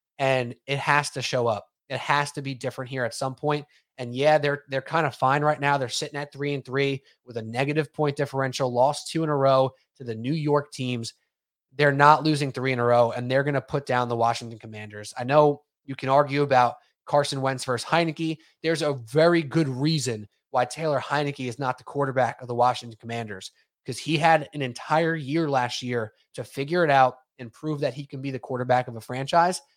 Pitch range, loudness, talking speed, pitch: 125-145 Hz, -25 LUFS, 220 wpm, 135 Hz